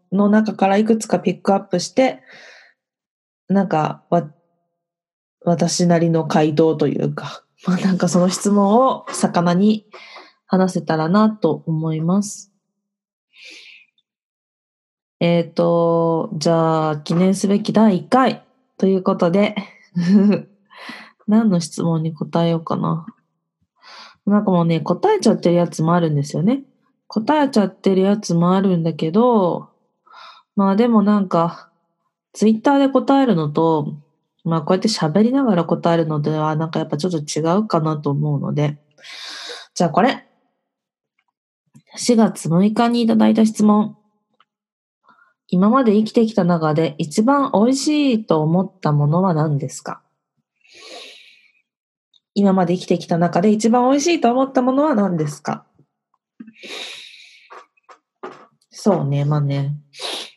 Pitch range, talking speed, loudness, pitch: 165-220 Hz, 250 characters per minute, -18 LUFS, 190 Hz